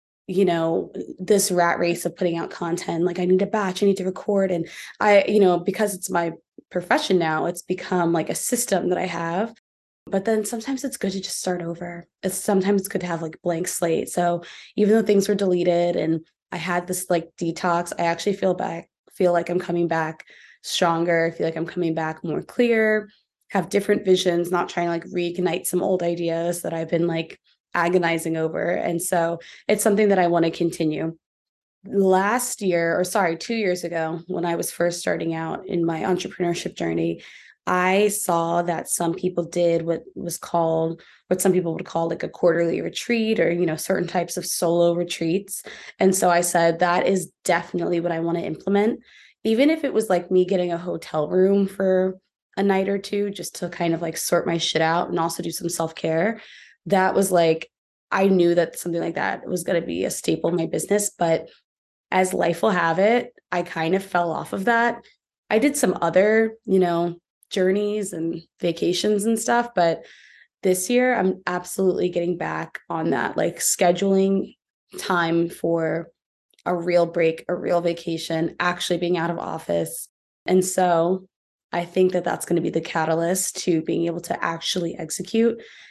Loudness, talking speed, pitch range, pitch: -22 LUFS, 190 wpm, 170-195 Hz, 175 Hz